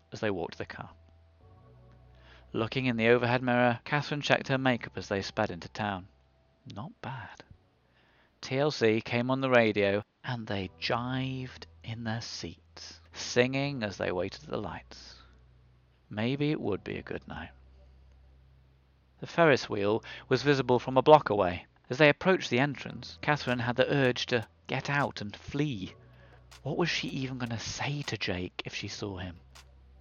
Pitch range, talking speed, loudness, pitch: 80-130 Hz, 165 wpm, -30 LUFS, 105 Hz